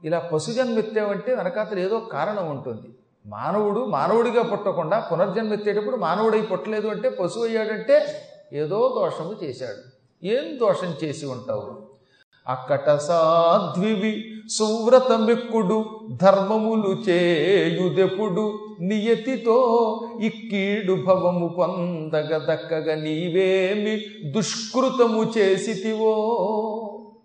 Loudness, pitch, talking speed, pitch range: -22 LUFS, 215 Hz, 80 wpm, 180-225 Hz